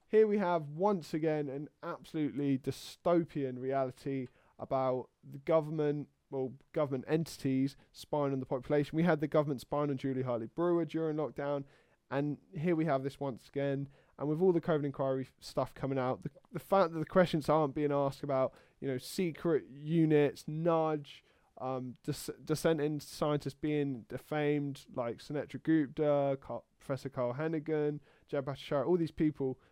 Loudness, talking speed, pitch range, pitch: -34 LUFS, 155 wpm, 135-160 Hz, 145 Hz